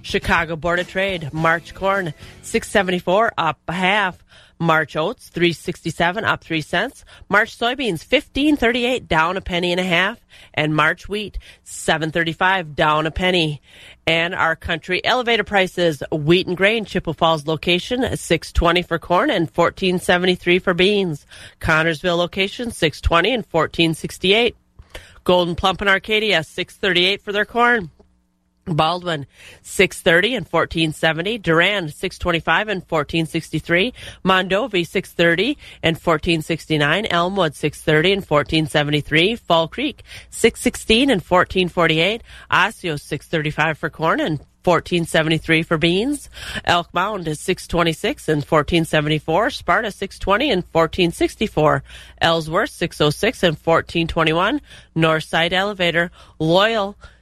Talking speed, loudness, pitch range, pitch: 115 wpm, -19 LUFS, 160-195 Hz, 175 Hz